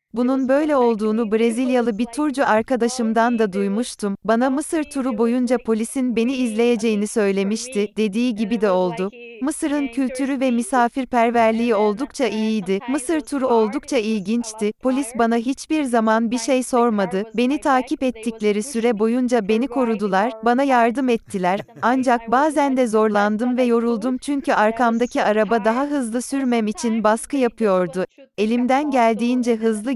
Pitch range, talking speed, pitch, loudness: 220-260 Hz, 130 wpm, 235 Hz, -20 LUFS